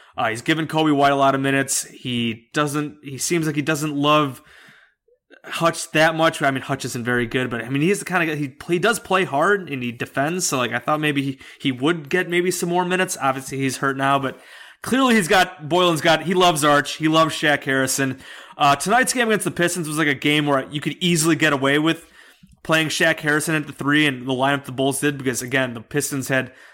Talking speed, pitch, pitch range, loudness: 240 wpm, 150 Hz, 135-170 Hz, -20 LUFS